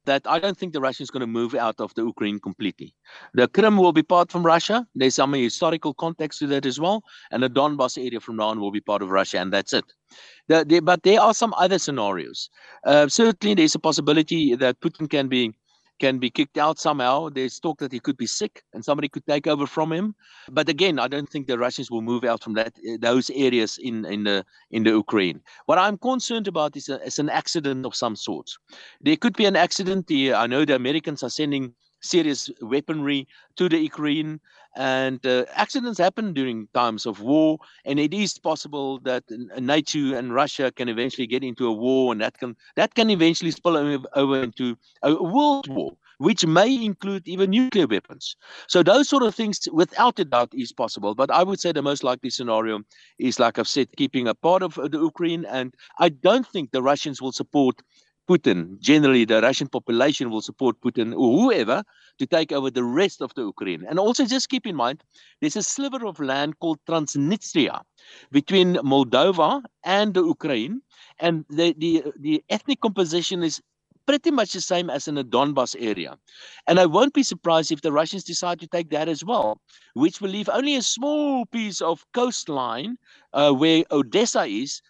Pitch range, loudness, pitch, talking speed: 130-185 Hz, -22 LUFS, 150 Hz, 200 wpm